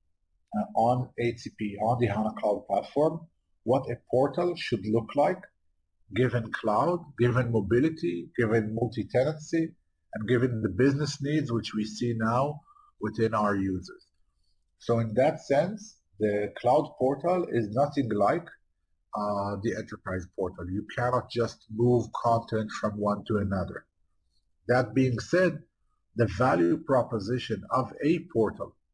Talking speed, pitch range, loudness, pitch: 135 wpm, 100-130 Hz, -28 LUFS, 115 Hz